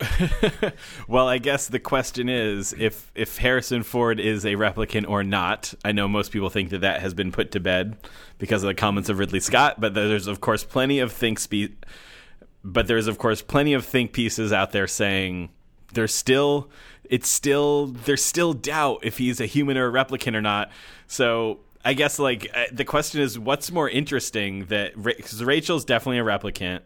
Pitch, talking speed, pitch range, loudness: 110 Hz, 190 wpm, 100-130 Hz, -23 LUFS